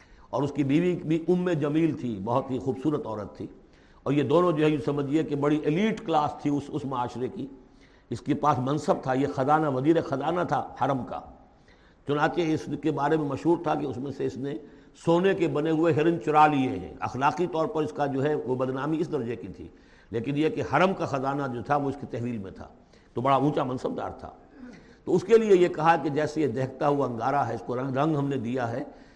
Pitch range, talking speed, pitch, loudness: 135-160 Hz, 240 wpm, 145 Hz, -26 LUFS